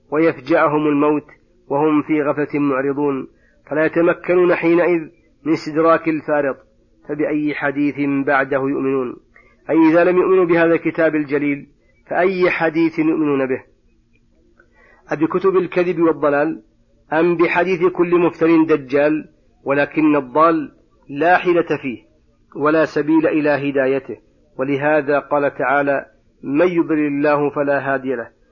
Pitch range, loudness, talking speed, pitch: 145-165 Hz, -17 LUFS, 115 wpm, 150 Hz